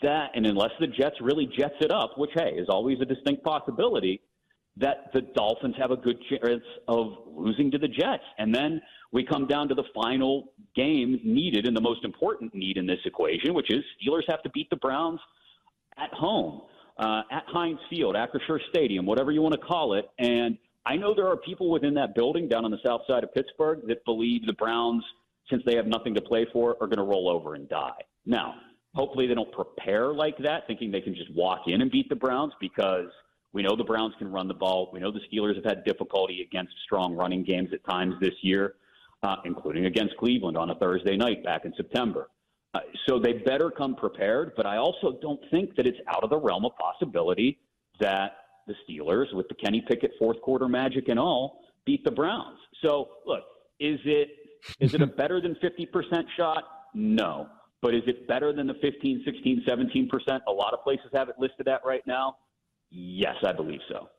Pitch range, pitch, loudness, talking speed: 110-150 Hz, 130 Hz, -28 LUFS, 210 wpm